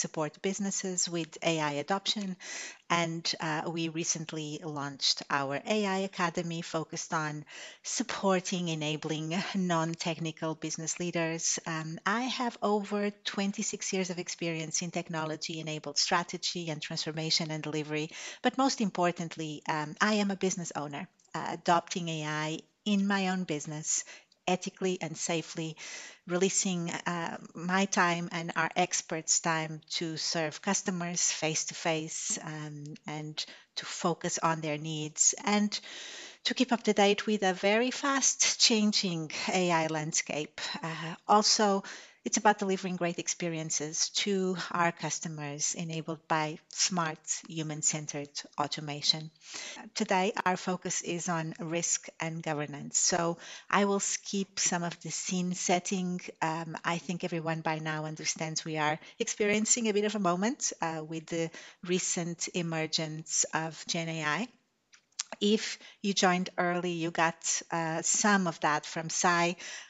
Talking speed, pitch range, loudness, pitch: 135 wpm, 160-195 Hz, -31 LUFS, 170 Hz